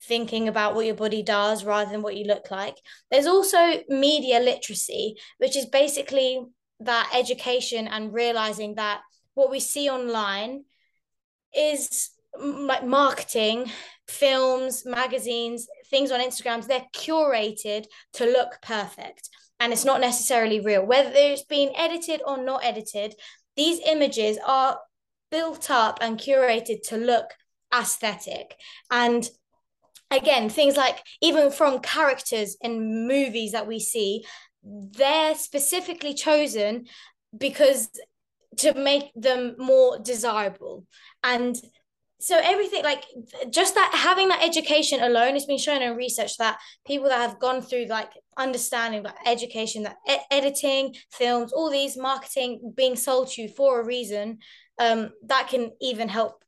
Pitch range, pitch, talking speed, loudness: 230-280 Hz, 255 Hz, 135 wpm, -23 LUFS